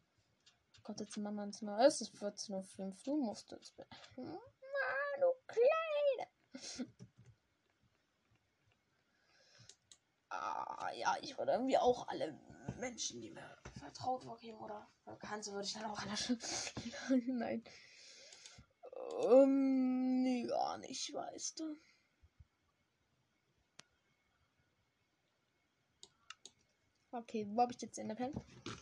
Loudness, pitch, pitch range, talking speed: -38 LUFS, 255 Hz, 220-285 Hz, 105 wpm